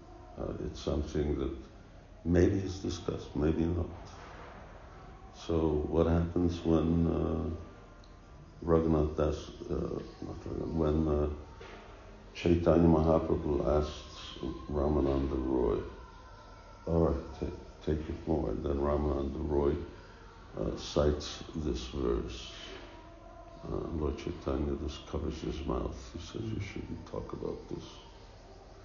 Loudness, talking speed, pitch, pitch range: -33 LUFS, 110 wpm, 80 Hz, 75-90 Hz